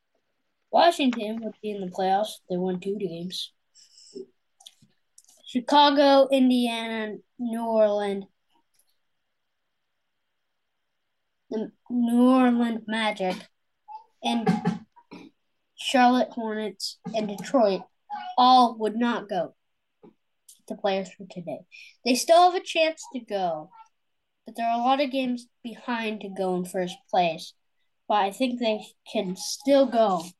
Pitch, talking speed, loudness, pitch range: 225 Hz, 115 wpm, -24 LUFS, 205-260 Hz